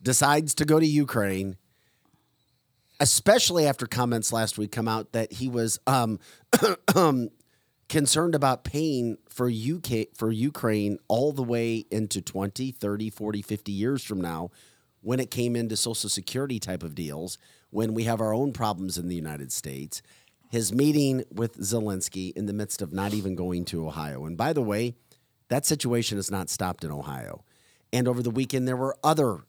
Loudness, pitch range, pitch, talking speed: -27 LUFS, 100-130 Hz, 115 Hz, 170 wpm